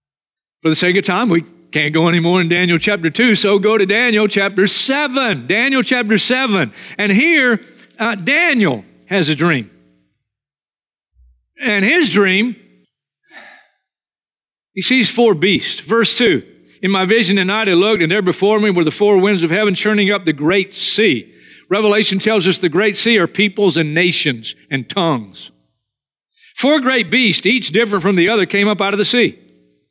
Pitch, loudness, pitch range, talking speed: 200 Hz, -14 LUFS, 170-220 Hz, 175 wpm